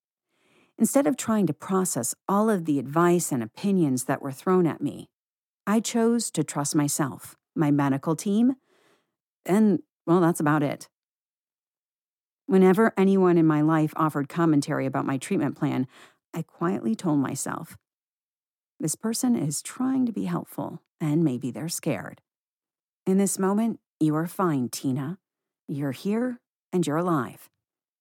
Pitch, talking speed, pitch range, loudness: 165 Hz, 145 wpm, 145-200 Hz, -25 LUFS